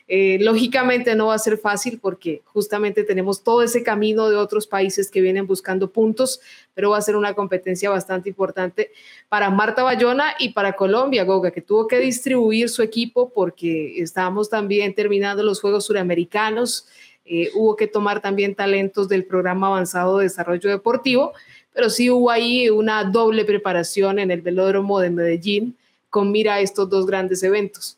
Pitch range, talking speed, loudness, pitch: 190-225 Hz, 170 wpm, -19 LUFS, 205 Hz